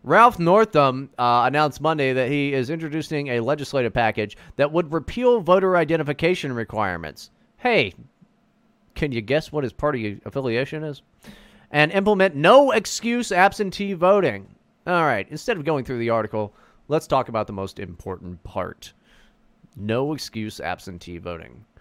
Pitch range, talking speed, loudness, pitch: 110-175 Hz, 145 wpm, -21 LUFS, 145 Hz